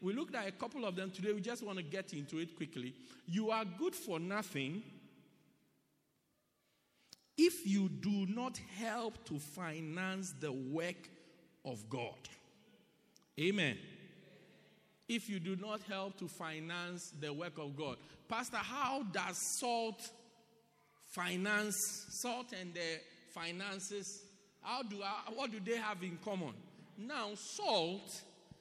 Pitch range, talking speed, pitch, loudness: 170-215 Hz, 130 wpm, 195 Hz, -41 LUFS